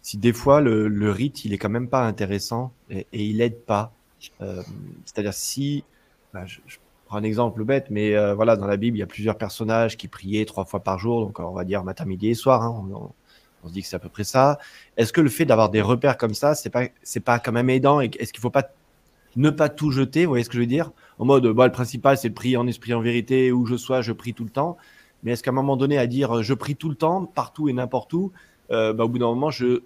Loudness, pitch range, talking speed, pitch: -22 LUFS, 105-135 Hz, 280 wpm, 120 Hz